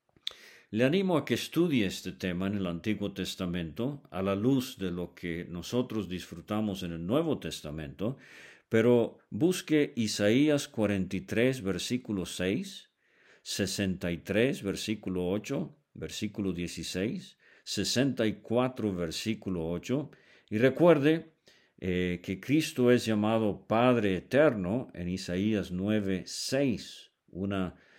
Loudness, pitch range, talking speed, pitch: -30 LUFS, 90-125 Hz, 110 wpm, 100 Hz